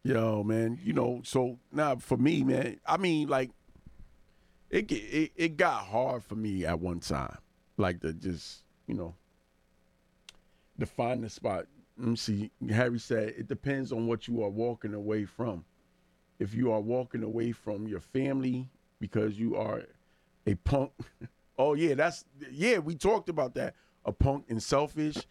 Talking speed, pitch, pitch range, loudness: 170 wpm, 115 Hz, 105-130 Hz, -32 LUFS